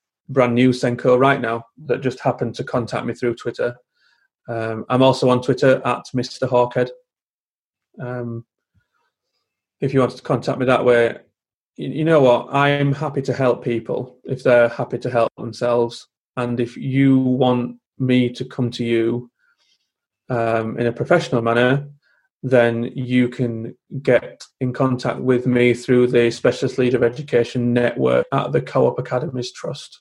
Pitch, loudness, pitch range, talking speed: 125 Hz, -19 LUFS, 120-130 Hz, 160 wpm